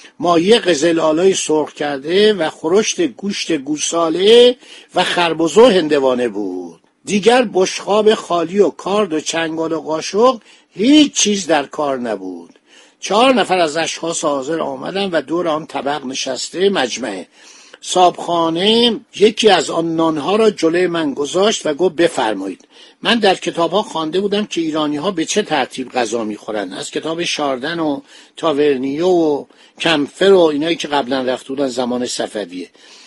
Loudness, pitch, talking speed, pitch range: -16 LUFS, 165 Hz, 140 wpm, 145-195 Hz